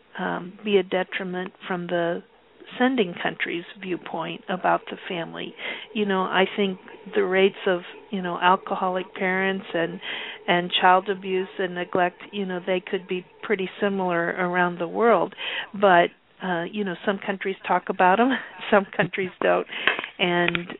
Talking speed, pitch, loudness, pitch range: 155 wpm, 185 Hz, -24 LUFS, 180-200 Hz